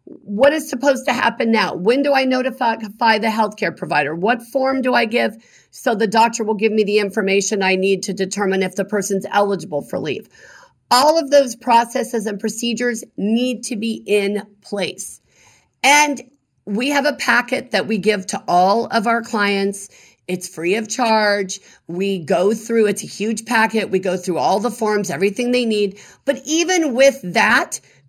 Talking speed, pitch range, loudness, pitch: 180 wpm, 200-245 Hz, -18 LUFS, 220 Hz